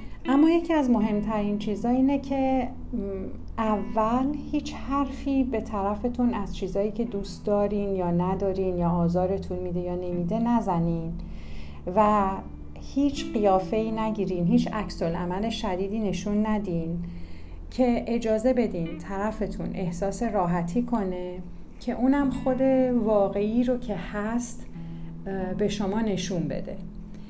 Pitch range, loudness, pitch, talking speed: 180-235 Hz, -26 LUFS, 205 Hz, 115 wpm